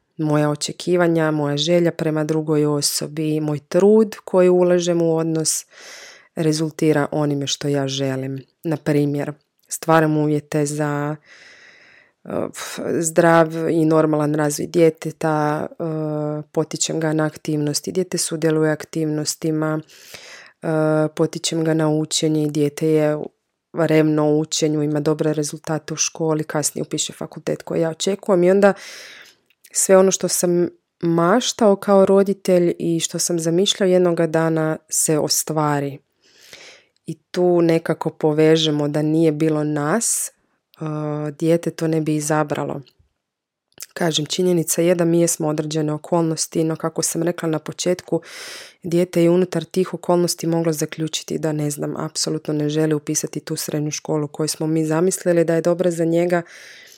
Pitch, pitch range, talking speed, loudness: 160 Hz, 155-170 Hz, 135 wpm, -19 LUFS